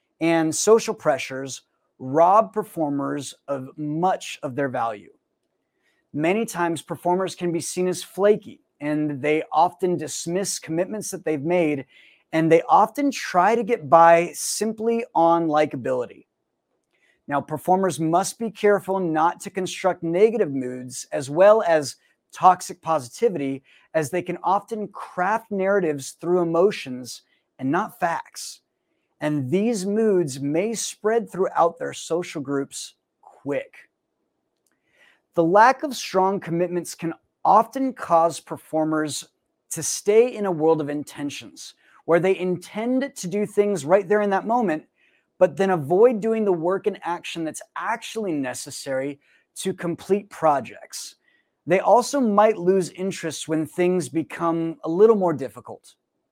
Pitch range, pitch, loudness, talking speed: 155-200 Hz, 175 Hz, -22 LUFS, 135 wpm